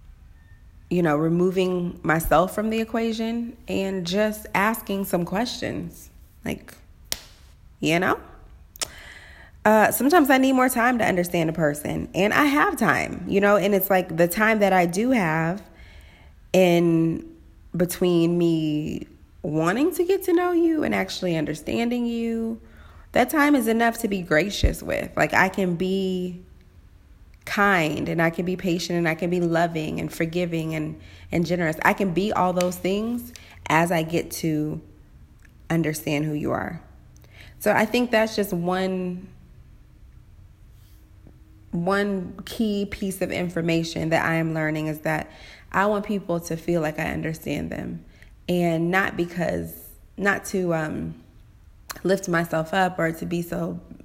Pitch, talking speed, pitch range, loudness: 175 Hz, 150 wpm, 155-200 Hz, -23 LUFS